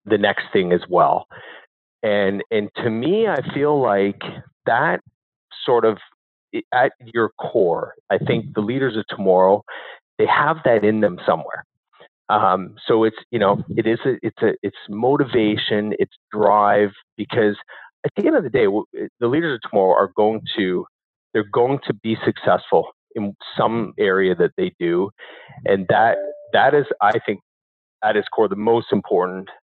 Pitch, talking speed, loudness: 110 Hz, 165 wpm, -19 LUFS